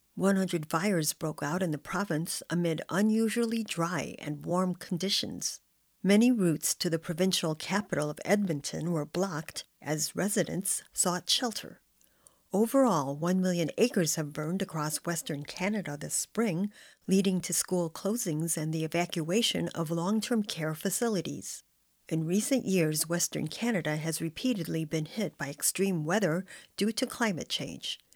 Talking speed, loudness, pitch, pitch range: 145 wpm, -30 LUFS, 180 Hz, 160-200 Hz